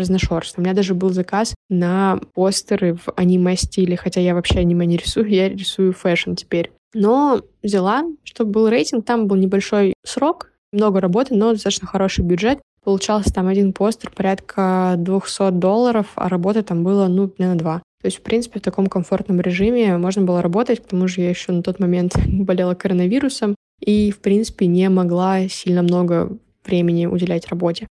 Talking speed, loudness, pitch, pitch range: 170 wpm, -18 LUFS, 190 Hz, 180-210 Hz